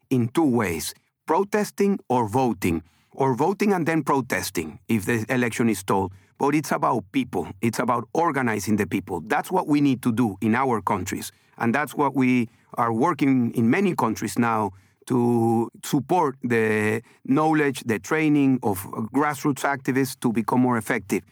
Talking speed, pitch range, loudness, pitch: 160 wpm, 110-140 Hz, -23 LUFS, 125 Hz